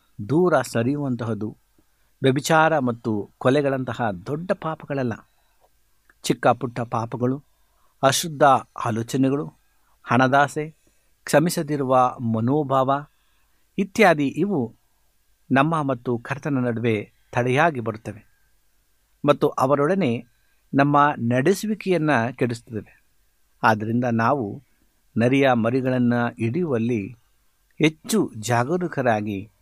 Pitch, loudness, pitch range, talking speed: 125 Hz, -22 LUFS, 115-145 Hz, 70 wpm